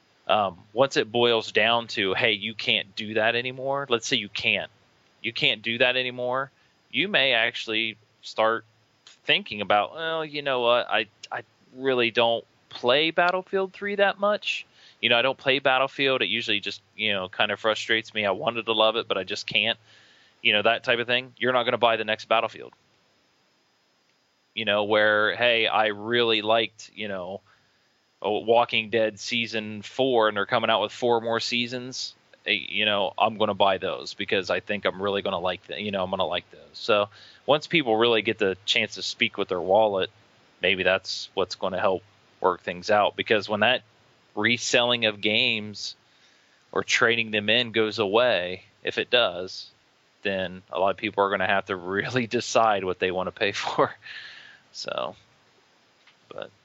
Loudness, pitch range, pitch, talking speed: -24 LUFS, 105-125 Hz, 115 Hz, 190 wpm